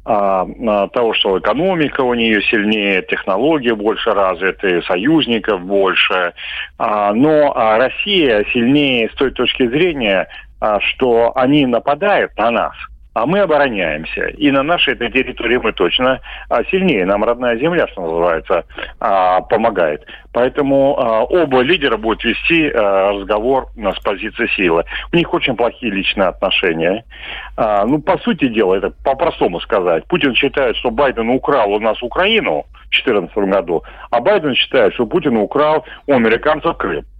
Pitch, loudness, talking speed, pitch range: 130 Hz, -15 LUFS, 130 wpm, 115-155 Hz